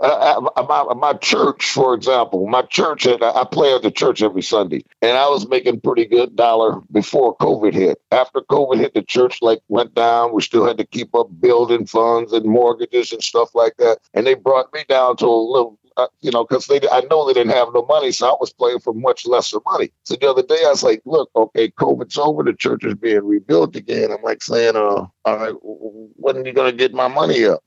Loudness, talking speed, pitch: -16 LUFS, 230 wpm, 130 Hz